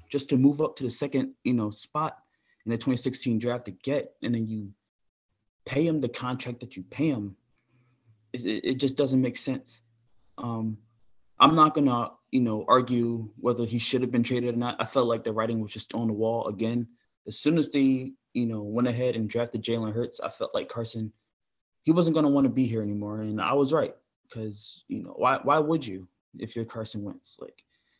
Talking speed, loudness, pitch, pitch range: 210 wpm, -27 LUFS, 120 Hz, 110-130 Hz